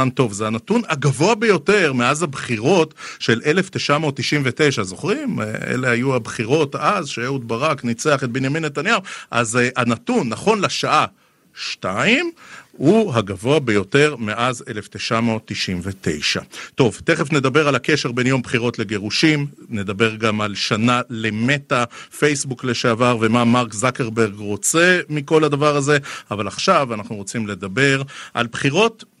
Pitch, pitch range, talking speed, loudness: 130 Hz, 115-150 Hz, 125 wpm, -19 LUFS